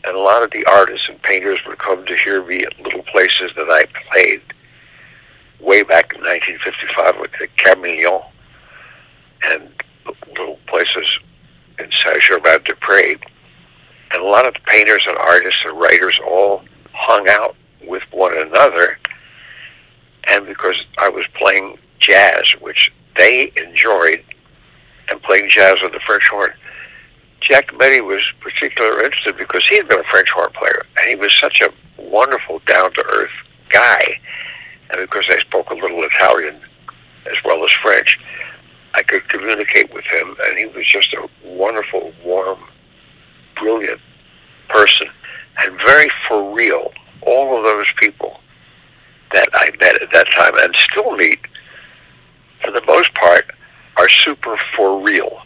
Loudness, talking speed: -12 LUFS, 150 wpm